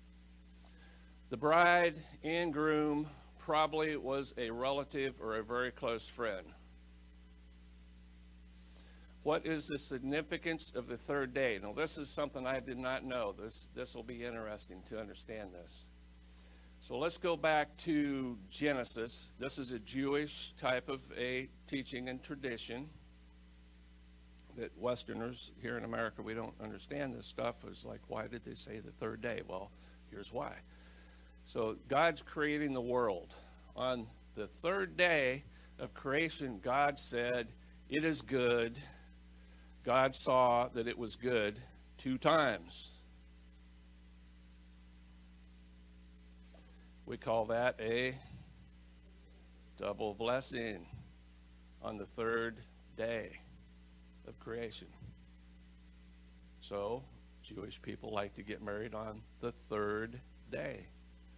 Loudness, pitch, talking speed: -38 LUFS, 110 Hz, 120 wpm